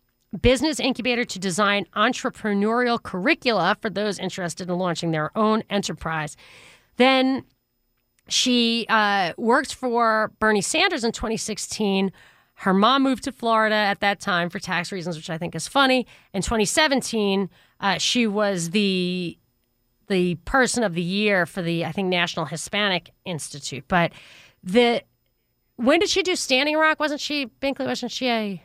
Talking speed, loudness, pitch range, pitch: 150 wpm, -22 LUFS, 175-245 Hz, 210 Hz